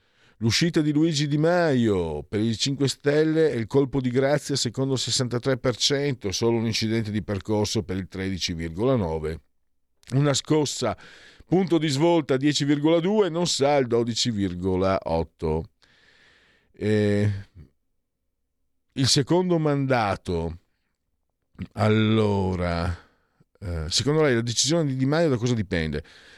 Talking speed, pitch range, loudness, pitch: 115 wpm, 95-145 Hz, -24 LUFS, 115 Hz